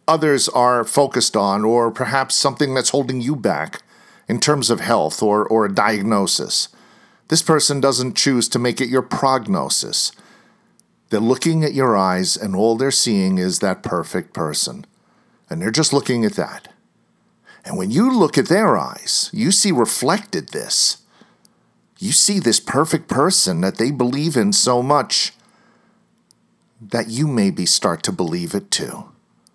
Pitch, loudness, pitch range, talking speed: 135 Hz, -17 LUFS, 120-160 Hz, 155 wpm